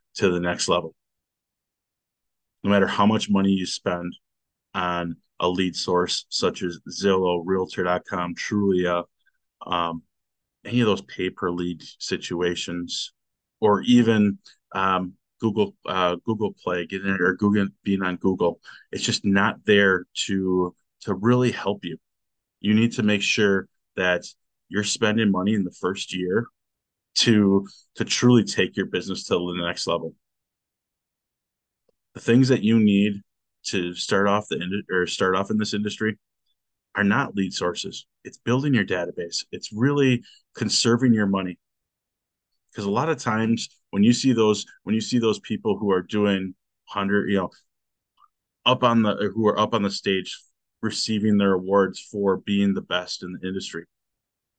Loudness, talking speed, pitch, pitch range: -23 LUFS, 155 wpm, 100 Hz, 90-110 Hz